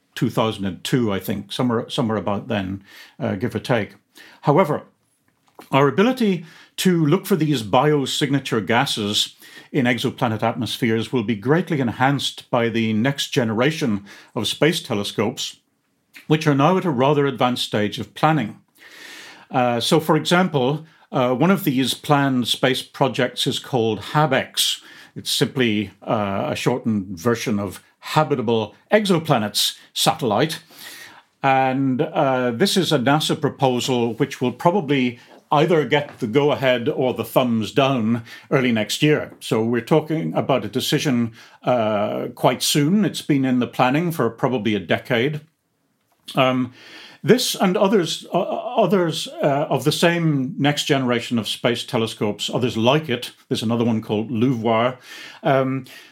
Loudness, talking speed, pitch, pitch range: -20 LUFS, 140 wpm, 130 Hz, 115-150 Hz